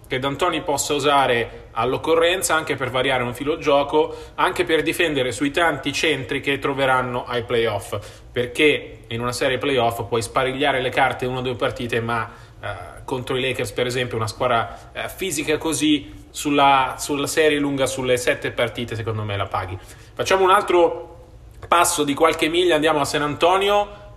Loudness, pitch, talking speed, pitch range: -20 LUFS, 135 Hz, 170 wpm, 120-150 Hz